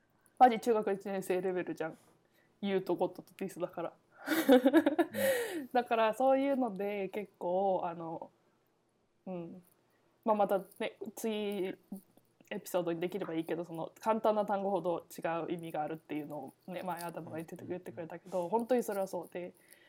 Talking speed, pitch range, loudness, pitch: 320 characters per minute, 175-220 Hz, -34 LUFS, 190 Hz